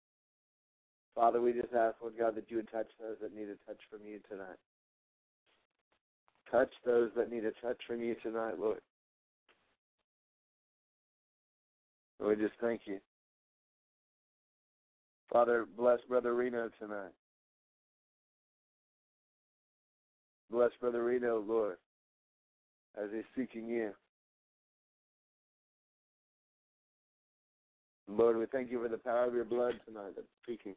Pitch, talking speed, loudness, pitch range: 115 Hz, 115 wpm, -35 LUFS, 110-120 Hz